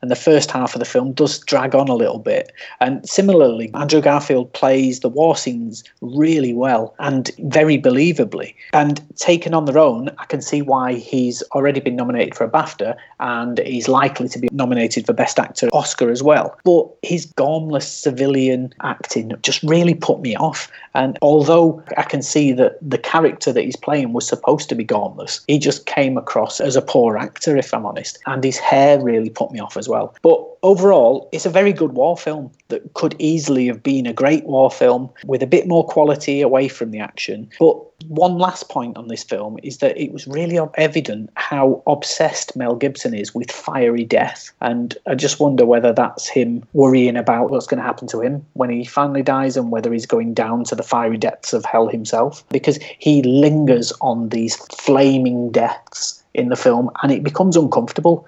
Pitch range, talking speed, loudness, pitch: 125-155 Hz, 195 wpm, -17 LUFS, 140 Hz